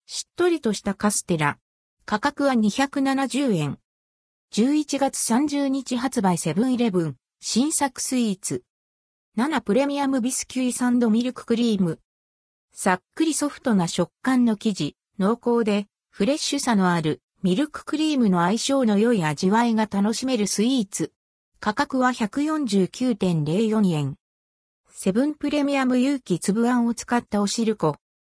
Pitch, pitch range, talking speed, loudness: 225 Hz, 180-260 Hz, 270 characters per minute, -23 LUFS